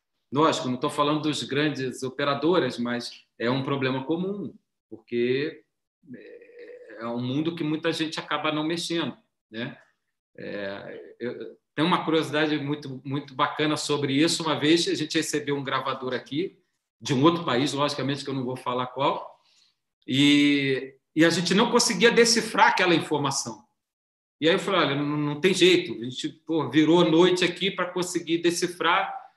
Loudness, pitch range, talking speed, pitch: -24 LUFS, 135-170 Hz, 155 wpm, 150 Hz